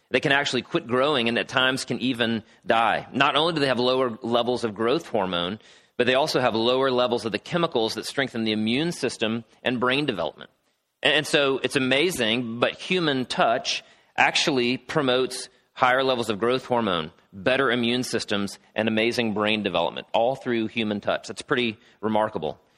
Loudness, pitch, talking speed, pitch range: -24 LUFS, 125 Hz, 175 wpm, 115-130 Hz